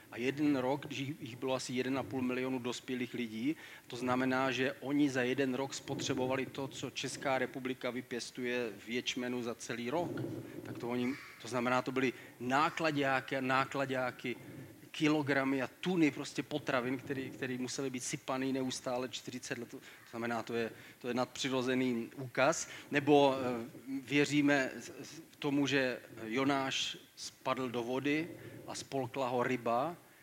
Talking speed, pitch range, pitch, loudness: 140 wpm, 125-140 Hz, 130 Hz, -35 LUFS